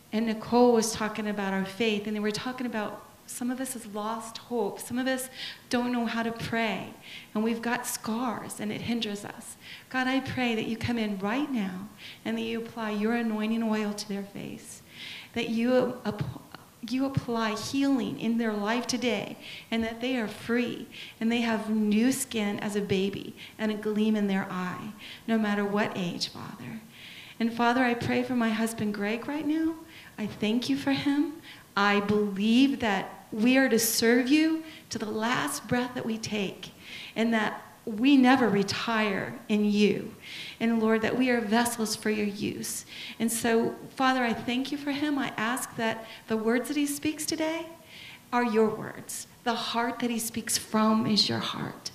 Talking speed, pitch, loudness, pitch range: 185 wpm, 225 Hz, -28 LUFS, 215-245 Hz